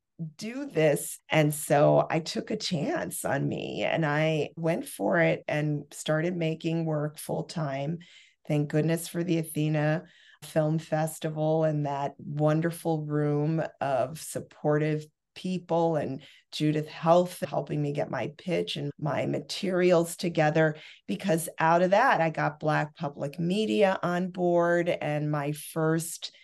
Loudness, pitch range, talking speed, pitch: -28 LUFS, 150-170 Hz, 140 wpm, 160 Hz